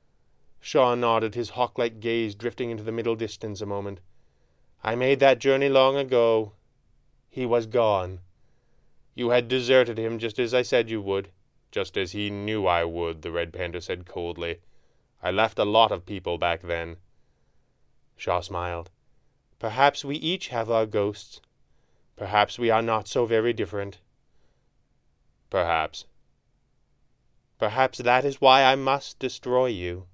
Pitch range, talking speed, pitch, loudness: 100-125 Hz, 145 wpm, 115 Hz, -25 LUFS